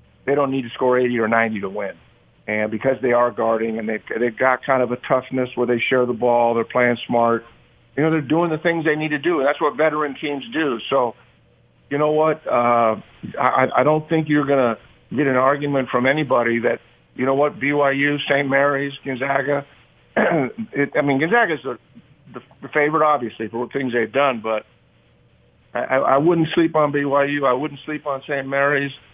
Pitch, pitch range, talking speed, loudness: 135 Hz, 120-145 Hz, 200 wpm, -20 LUFS